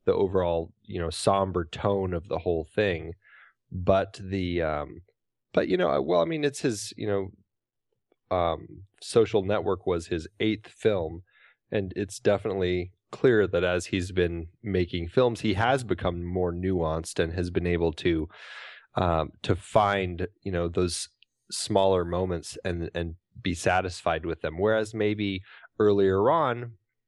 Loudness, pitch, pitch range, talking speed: -27 LUFS, 95 Hz, 85-105 Hz, 150 wpm